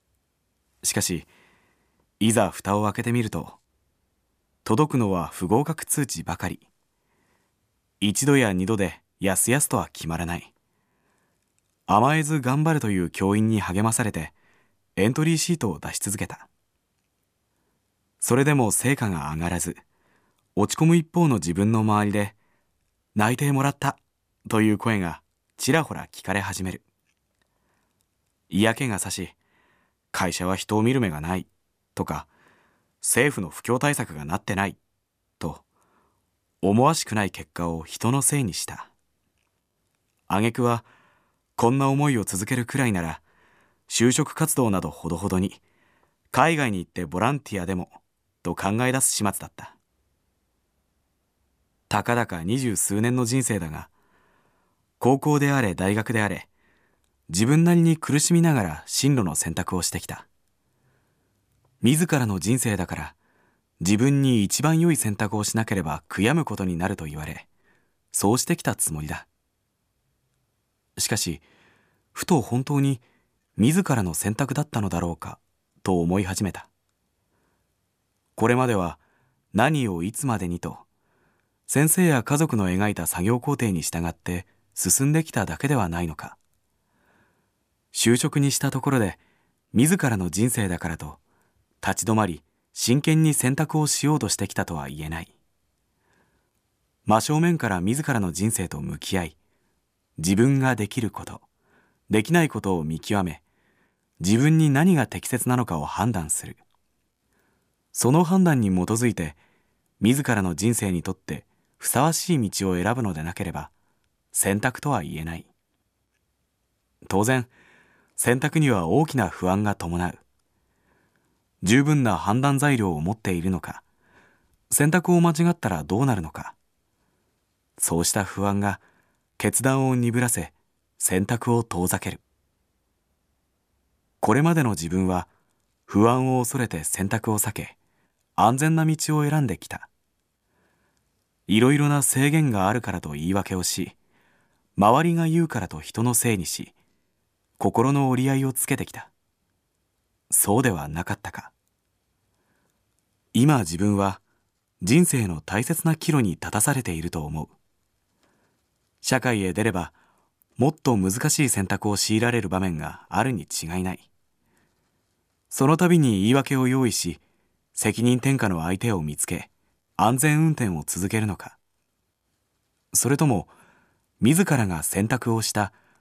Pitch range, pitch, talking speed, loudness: 90-130 Hz, 105 Hz, 255 characters per minute, -23 LUFS